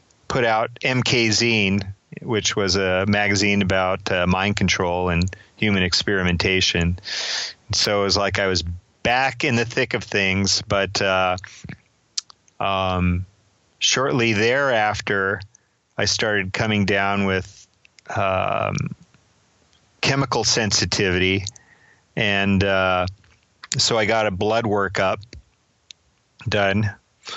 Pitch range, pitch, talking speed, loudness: 95-110 Hz, 100 Hz, 105 wpm, -20 LUFS